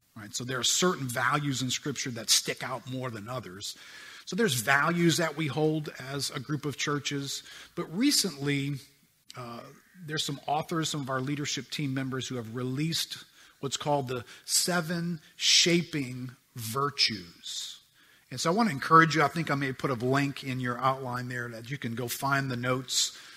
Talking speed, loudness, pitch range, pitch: 180 wpm, -29 LUFS, 125-155 Hz, 140 Hz